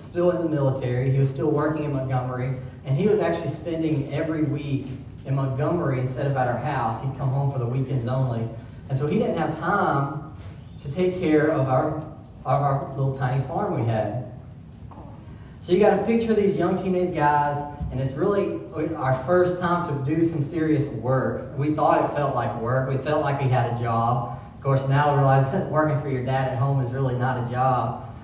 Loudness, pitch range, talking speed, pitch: -24 LUFS, 130-155 Hz, 210 wpm, 135 Hz